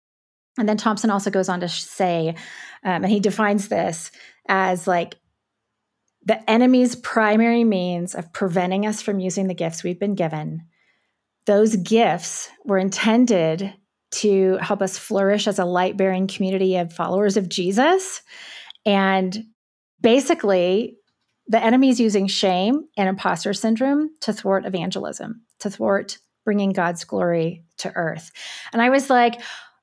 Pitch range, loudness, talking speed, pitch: 185-225 Hz, -20 LUFS, 135 wpm, 200 Hz